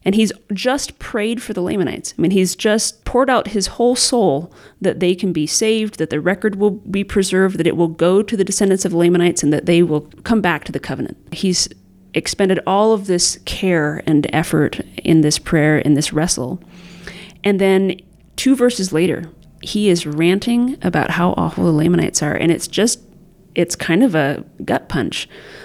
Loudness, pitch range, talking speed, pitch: -17 LUFS, 165-205 Hz, 190 wpm, 180 Hz